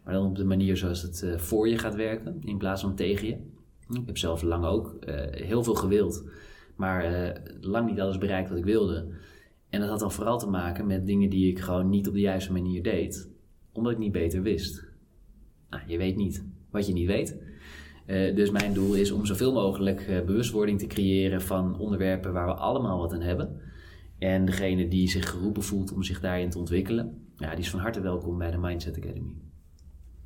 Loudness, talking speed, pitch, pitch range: -28 LUFS, 200 wpm, 95 Hz, 85-100 Hz